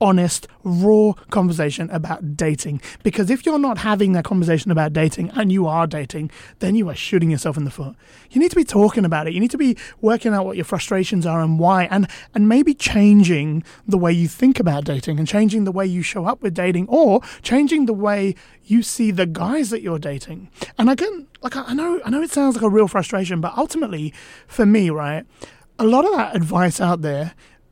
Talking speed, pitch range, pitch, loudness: 220 wpm, 165-225 Hz, 190 Hz, -18 LUFS